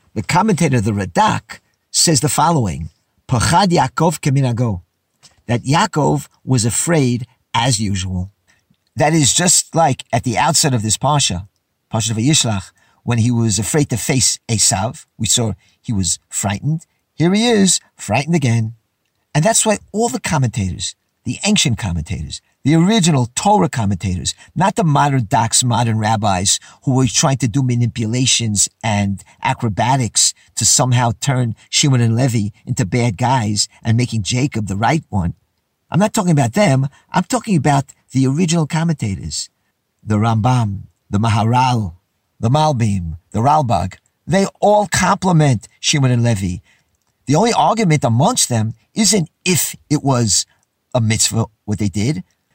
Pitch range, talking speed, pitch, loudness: 105-150 Hz, 145 wpm, 120 Hz, -16 LUFS